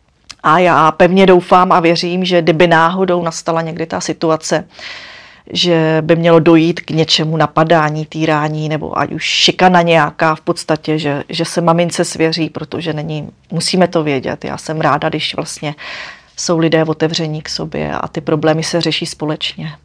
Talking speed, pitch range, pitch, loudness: 165 wpm, 155-175 Hz, 160 Hz, -13 LUFS